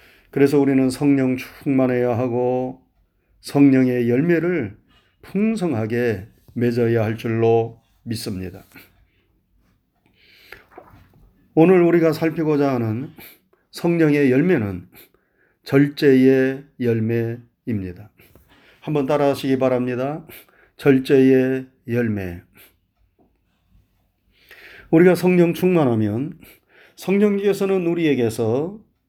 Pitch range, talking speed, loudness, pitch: 110-145 Hz, 195 characters per minute, -19 LUFS, 125 Hz